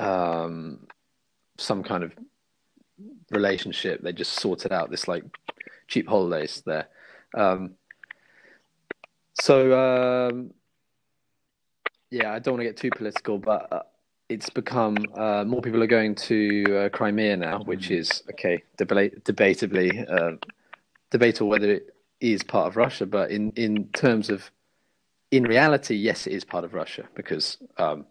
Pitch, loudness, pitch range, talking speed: 105 Hz, -25 LUFS, 100-115 Hz, 145 wpm